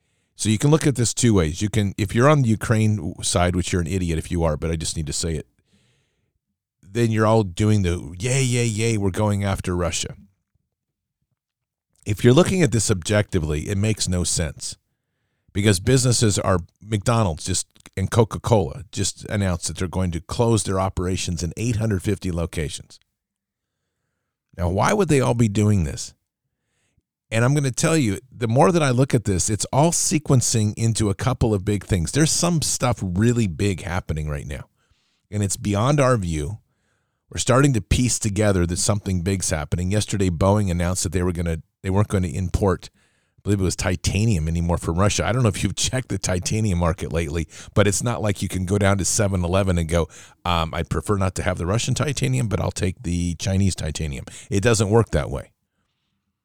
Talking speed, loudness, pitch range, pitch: 200 wpm, -21 LUFS, 90-115 Hz, 100 Hz